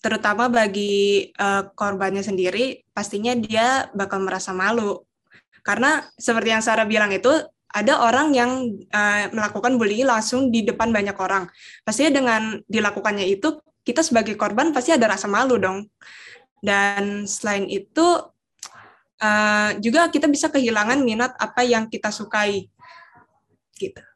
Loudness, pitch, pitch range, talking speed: -20 LUFS, 220 Hz, 205-250 Hz, 130 wpm